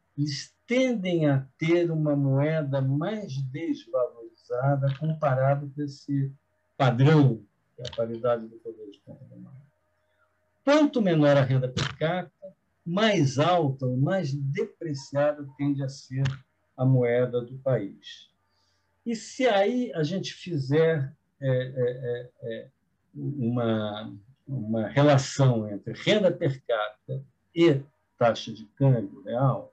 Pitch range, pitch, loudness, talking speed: 125-155 Hz, 140 Hz, -26 LUFS, 115 wpm